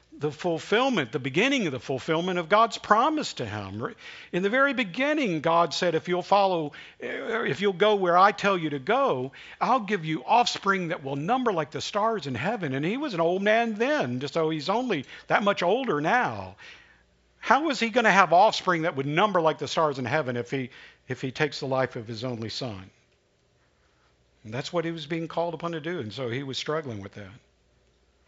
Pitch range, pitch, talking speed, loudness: 135-195 Hz, 160 Hz, 210 wpm, -25 LUFS